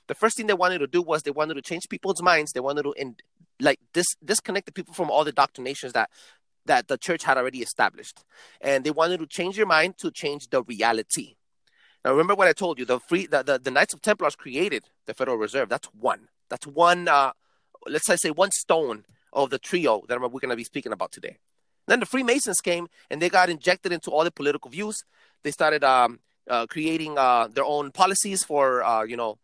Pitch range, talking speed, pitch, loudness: 140-185 Hz, 220 wpm, 160 Hz, -24 LUFS